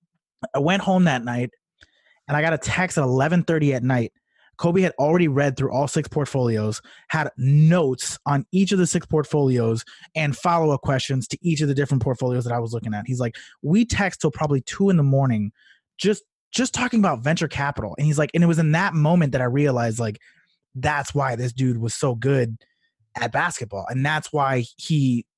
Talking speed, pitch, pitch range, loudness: 205 wpm, 145 Hz, 125-165 Hz, -22 LUFS